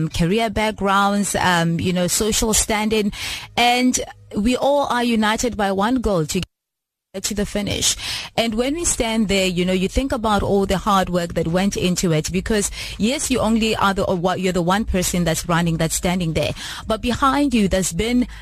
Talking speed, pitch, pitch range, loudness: 190 wpm, 200 Hz, 185-225 Hz, -19 LUFS